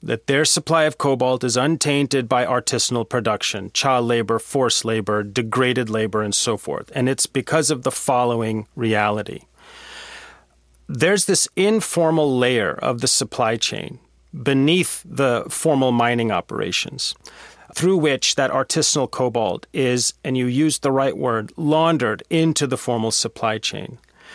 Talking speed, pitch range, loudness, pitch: 140 wpm, 115-150 Hz, -19 LUFS, 130 Hz